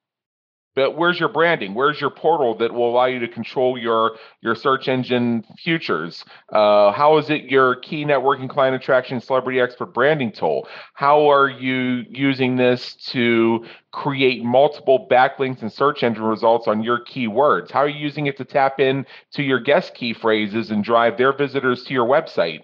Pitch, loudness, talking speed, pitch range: 130 Hz, -19 LUFS, 180 wpm, 115-140 Hz